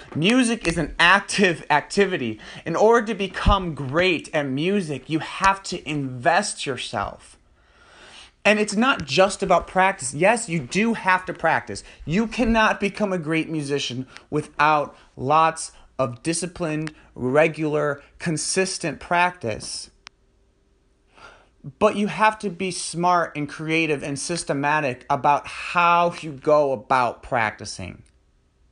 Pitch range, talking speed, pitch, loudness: 145-190 Hz, 120 wpm, 165 Hz, -22 LUFS